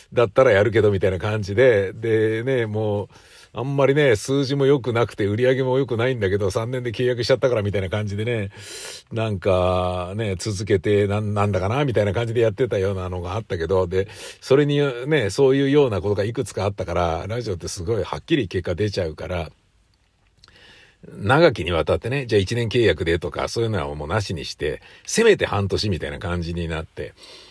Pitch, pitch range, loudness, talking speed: 105 Hz, 95-120 Hz, -21 LUFS, 410 characters per minute